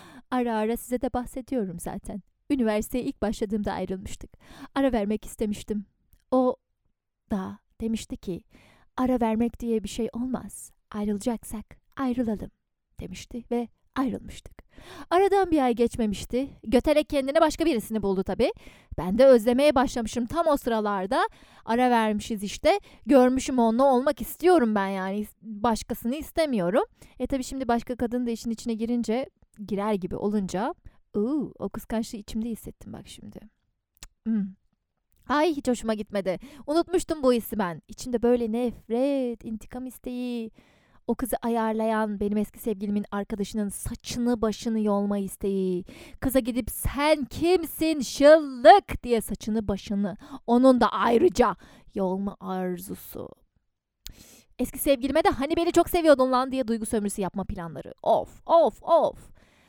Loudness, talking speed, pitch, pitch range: -26 LUFS, 130 wpm, 235 Hz, 210-265 Hz